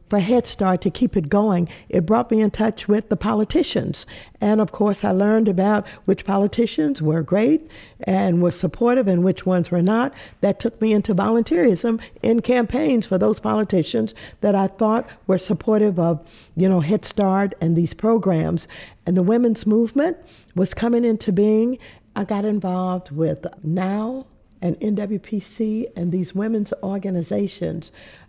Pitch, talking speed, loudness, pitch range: 205 Hz, 160 wpm, -20 LUFS, 185-220 Hz